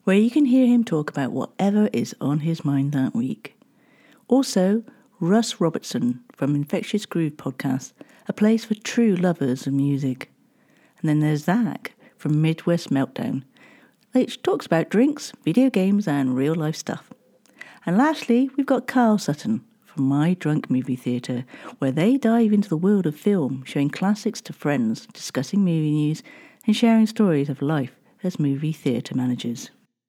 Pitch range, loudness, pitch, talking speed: 145-225 Hz, -22 LUFS, 185 Hz, 160 wpm